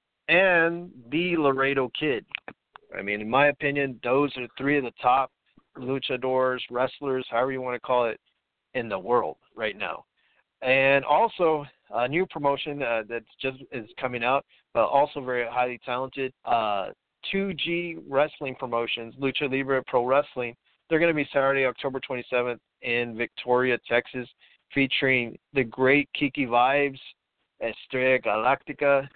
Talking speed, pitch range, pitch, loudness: 140 wpm, 125-145 Hz, 135 Hz, -26 LUFS